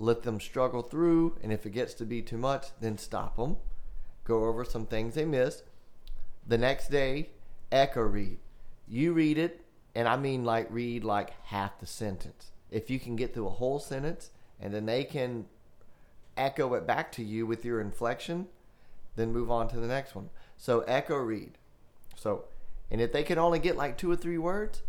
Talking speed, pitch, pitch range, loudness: 195 wpm, 120 Hz, 110-140 Hz, -32 LUFS